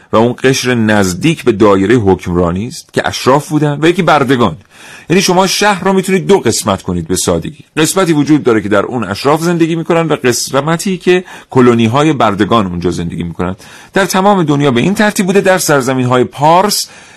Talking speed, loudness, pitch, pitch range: 185 wpm, -11 LUFS, 145 Hz, 110-180 Hz